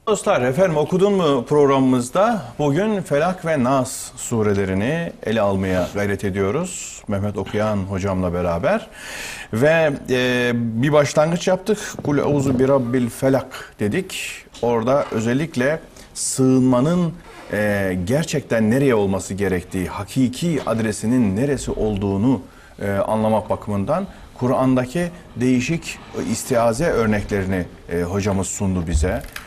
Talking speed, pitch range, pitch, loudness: 100 wpm, 100-145 Hz, 120 Hz, -20 LUFS